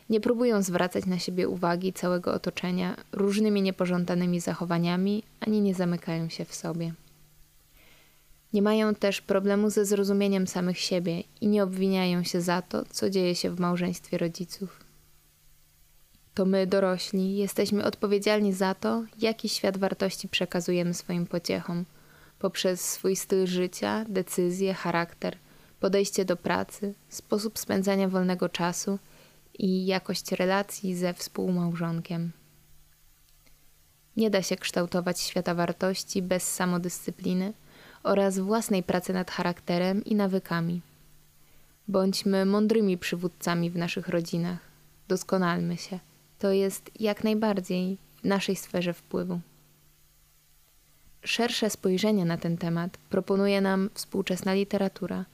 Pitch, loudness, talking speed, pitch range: 185 Hz, -28 LUFS, 115 wpm, 175-200 Hz